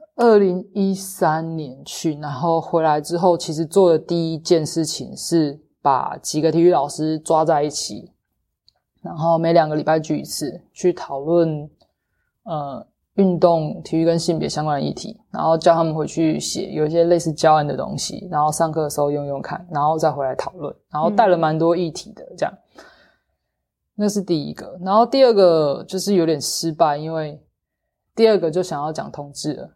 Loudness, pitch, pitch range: -19 LUFS, 165 Hz, 150-180 Hz